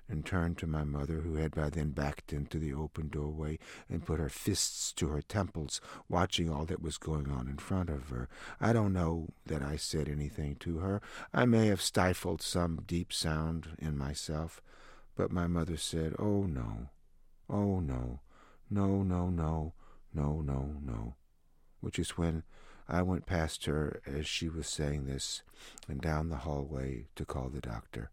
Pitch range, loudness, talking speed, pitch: 75-85 Hz, -35 LUFS, 175 wpm, 80 Hz